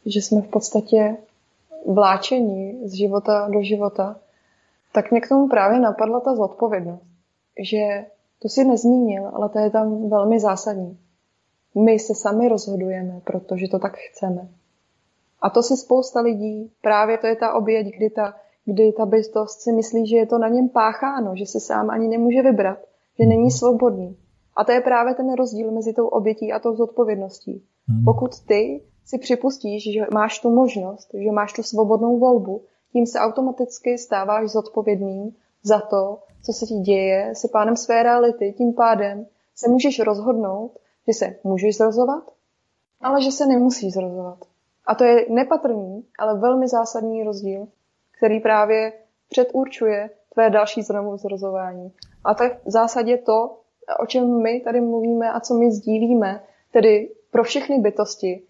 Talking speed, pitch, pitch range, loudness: 160 wpm, 220 Hz, 205-235 Hz, -20 LUFS